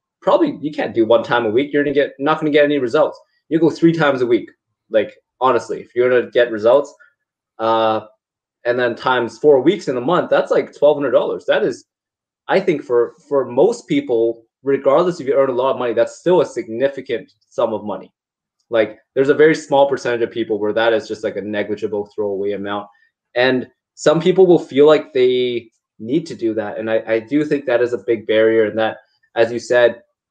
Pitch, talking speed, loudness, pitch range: 130 Hz, 215 wpm, -17 LUFS, 115-155 Hz